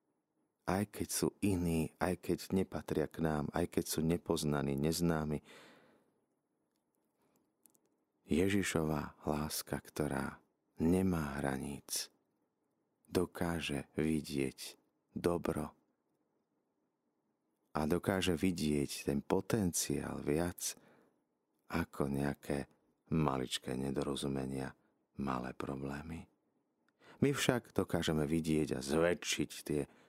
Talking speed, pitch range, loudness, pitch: 80 wpm, 70-85 Hz, -37 LUFS, 75 Hz